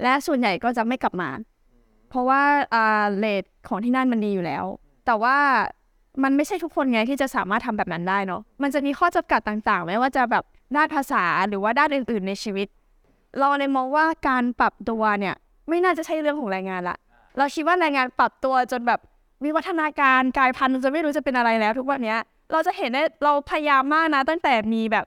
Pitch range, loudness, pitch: 220-290 Hz, -22 LUFS, 260 Hz